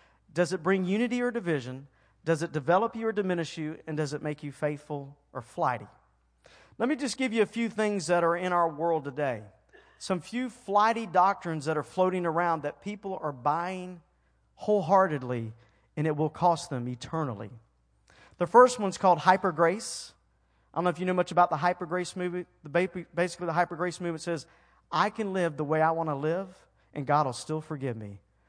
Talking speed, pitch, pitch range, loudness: 200 wpm, 170 Hz, 150-185 Hz, -29 LUFS